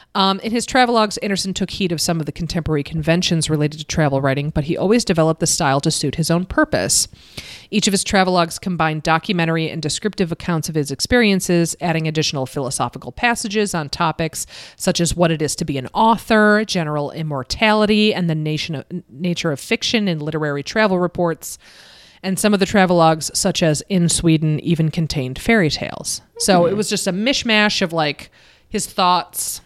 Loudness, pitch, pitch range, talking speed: -18 LUFS, 170 Hz, 155-195 Hz, 185 wpm